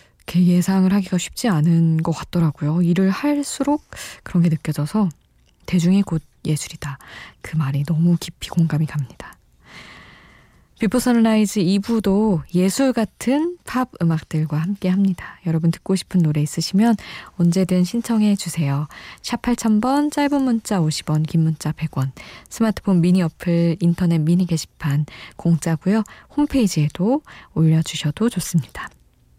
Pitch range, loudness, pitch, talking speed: 160-215 Hz, -20 LUFS, 175 Hz, 285 characters per minute